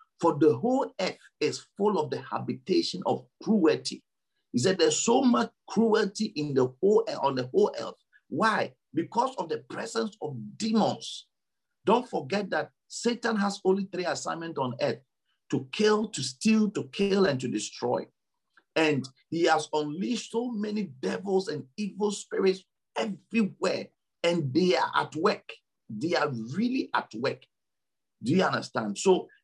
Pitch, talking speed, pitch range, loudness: 195 Hz, 155 wpm, 155-220 Hz, -28 LUFS